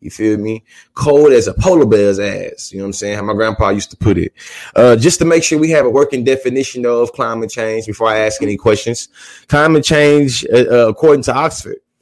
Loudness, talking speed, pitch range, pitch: -12 LUFS, 225 wpm, 110-145 Hz, 120 Hz